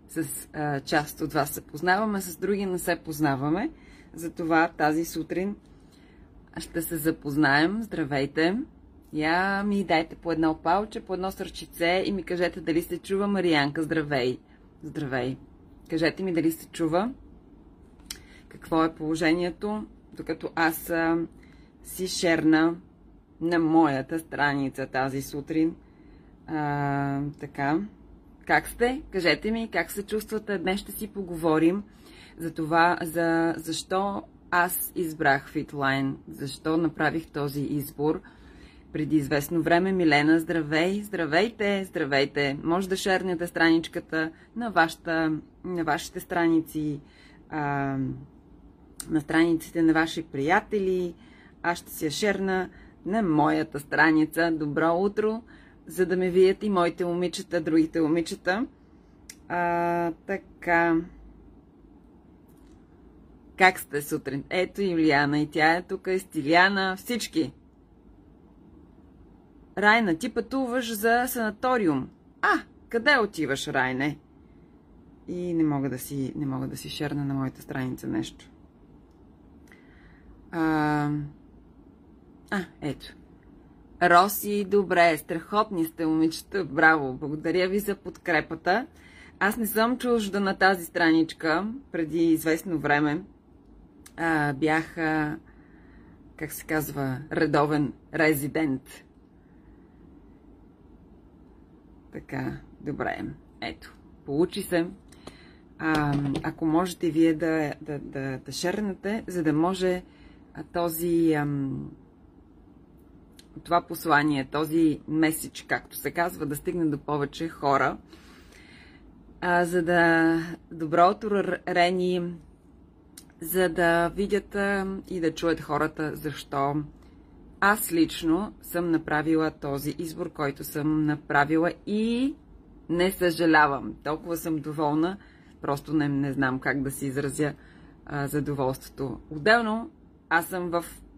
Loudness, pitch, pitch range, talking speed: -26 LUFS, 165 Hz, 150-180 Hz, 110 wpm